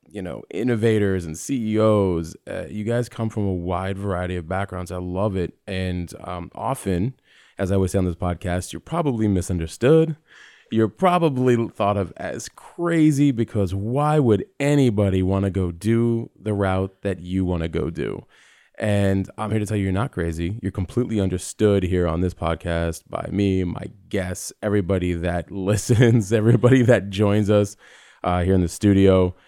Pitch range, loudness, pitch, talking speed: 90-115 Hz, -22 LUFS, 100 Hz, 175 wpm